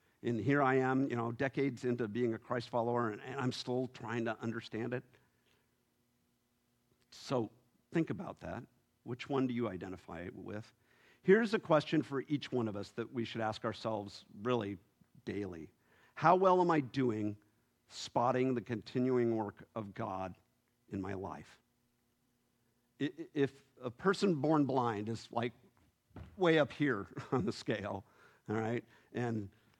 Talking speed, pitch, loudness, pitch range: 150 wpm, 120 Hz, -36 LUFS, 110-130 Hz